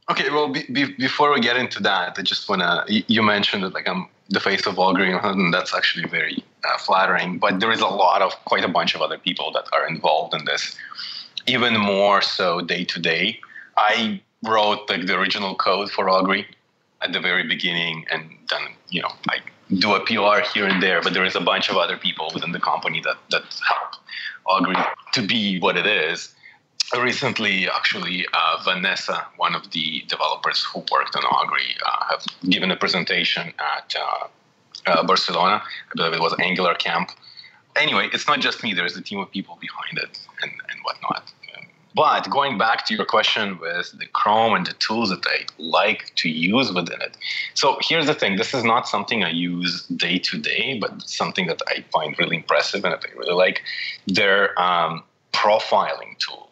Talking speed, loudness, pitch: 195 wpm, -21 LUFS, 125 Hz